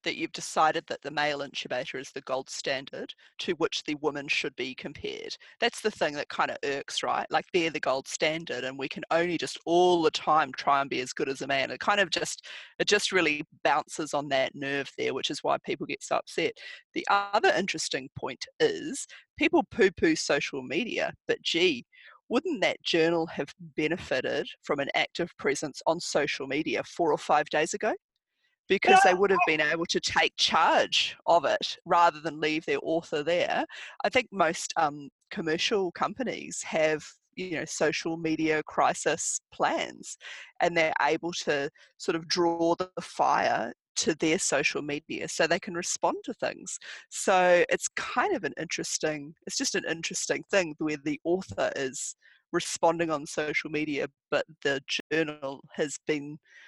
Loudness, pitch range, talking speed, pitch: -28 LUFS, 155-225 Hz, 180 wpm, 170 Hz